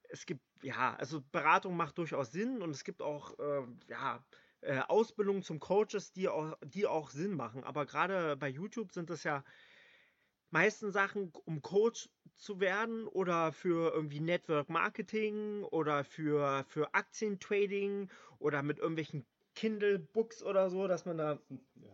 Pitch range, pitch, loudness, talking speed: 150-205 Hz, 175 Hz, -36 LUFS, 150 wpm